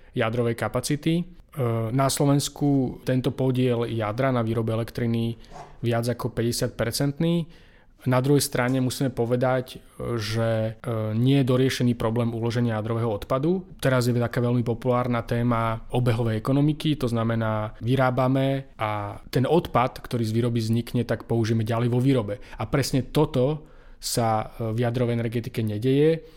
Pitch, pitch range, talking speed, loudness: 120 Hz, 115-130 Hz, 130 wpm, -25 LUFS